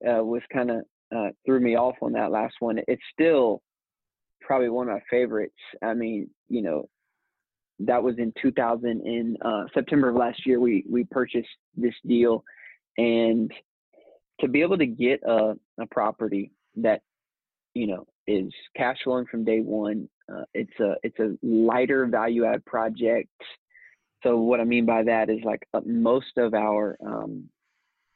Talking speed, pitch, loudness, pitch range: 165 wpm, 115 Hz, -25 LUFS, 110-125 Hz